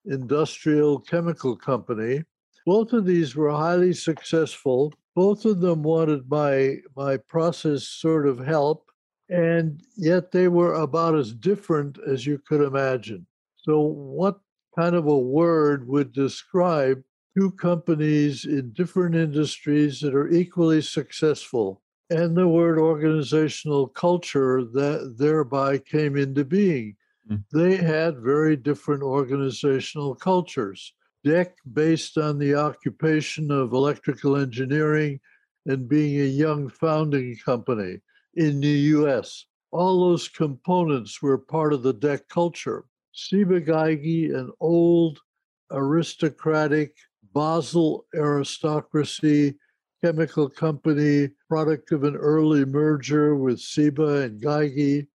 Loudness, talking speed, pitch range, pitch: -23 LUFS, 115 wpm, 140-165 Hz, 150 Hz